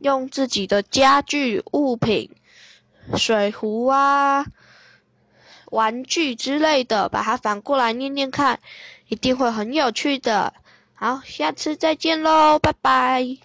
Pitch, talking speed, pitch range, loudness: 270 Hz, 175 characters per minute, 240-285 Hz, -20 LUFS